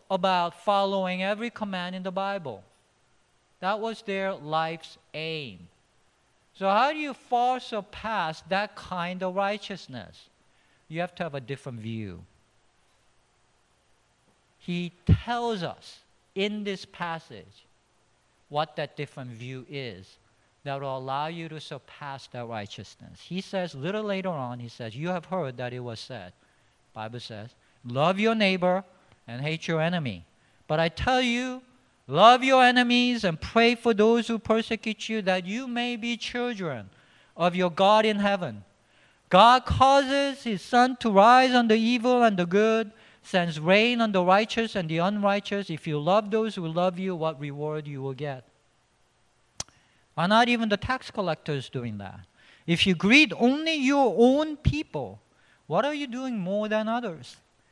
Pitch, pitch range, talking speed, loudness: 180 Hz, 135-220 Hz, 155 wpm, -25 LUFS